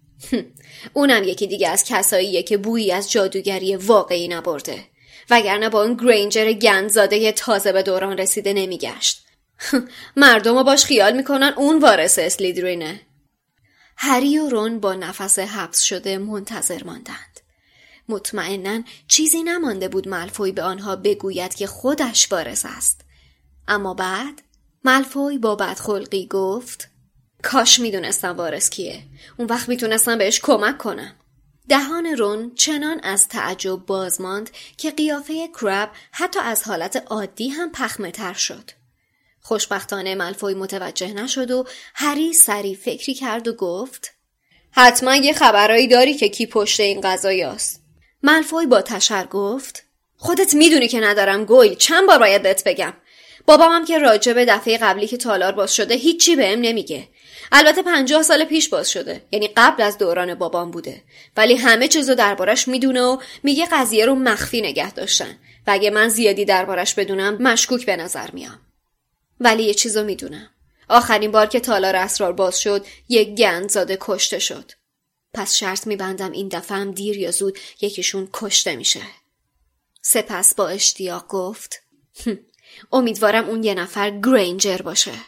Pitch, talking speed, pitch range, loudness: 210 Hz, 140 wpm, 190-250 Hz, -17 LUFS